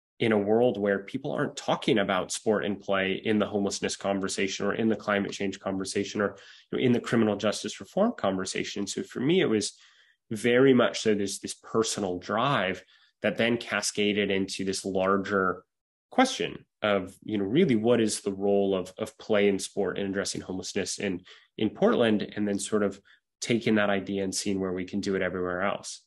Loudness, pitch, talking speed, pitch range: -27 LUFS, 100 Hz, 190 wpm, 95-105 Hz